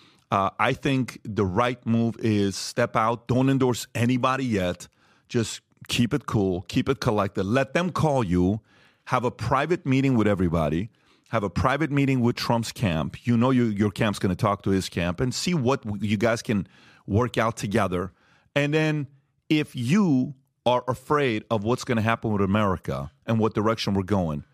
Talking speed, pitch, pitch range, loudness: 185 wpm, 115 Hz, 105-130 Hz, -25 LUFS